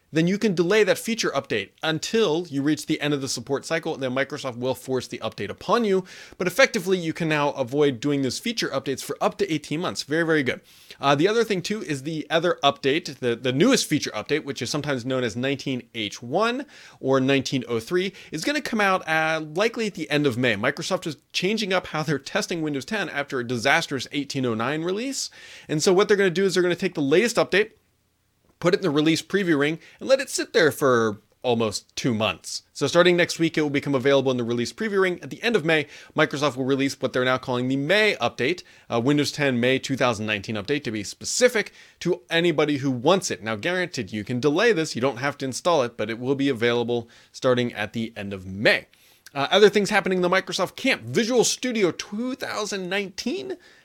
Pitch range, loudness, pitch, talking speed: 130-185 Hz, -23 LUFS, 145 Hz, 215 wpm